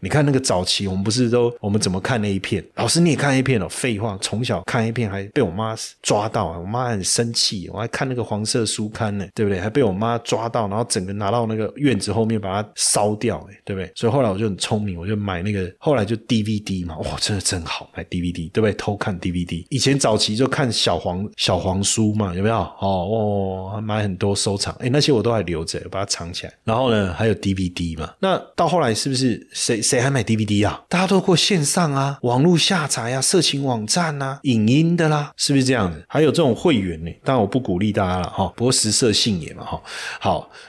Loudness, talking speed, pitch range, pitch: -20 LUFS, 350 characters per minute, 95-125 Hz, 110 Hz